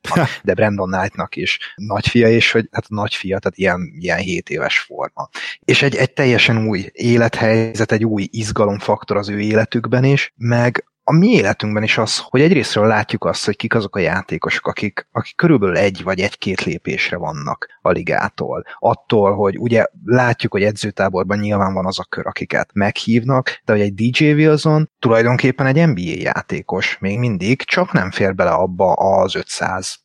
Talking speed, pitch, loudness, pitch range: 170 wpm, 115 Hz, -17 LUFS, 105-125 Hz